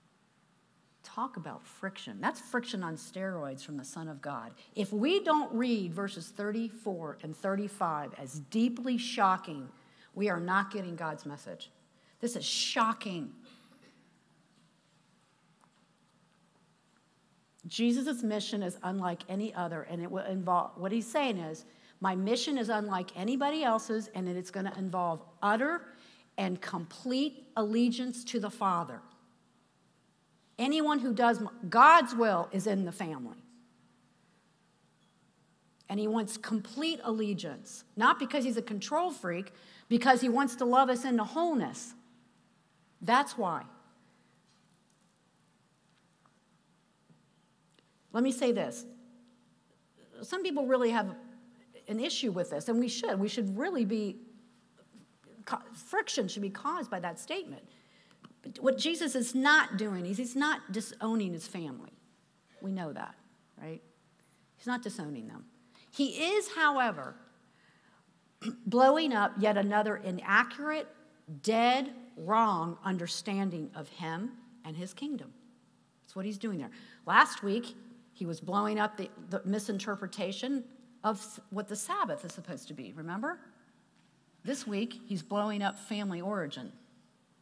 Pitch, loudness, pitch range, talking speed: 220 Hz, -32 LUFS, 190-245 Hz, 130 wpm